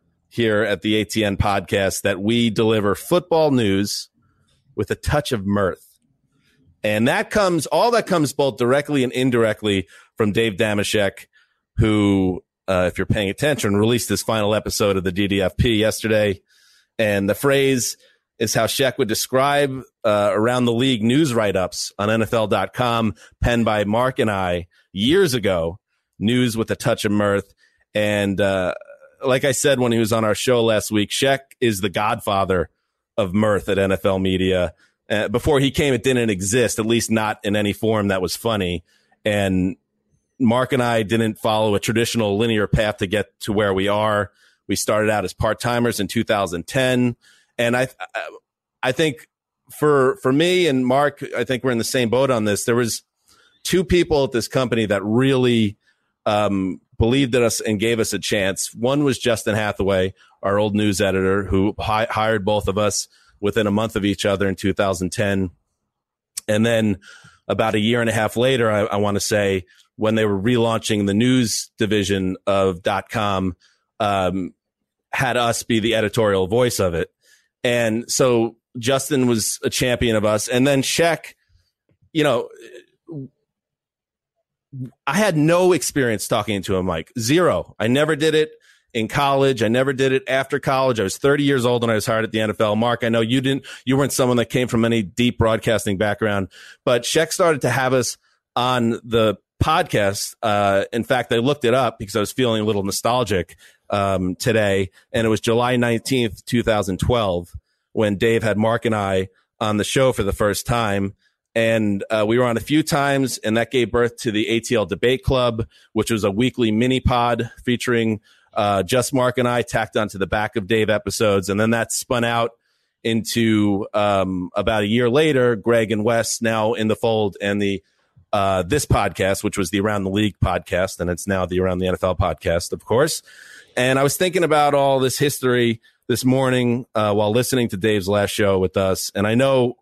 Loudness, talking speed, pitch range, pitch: -20 LUFS, 185 wpm, 100-125 Hz, 110 Hz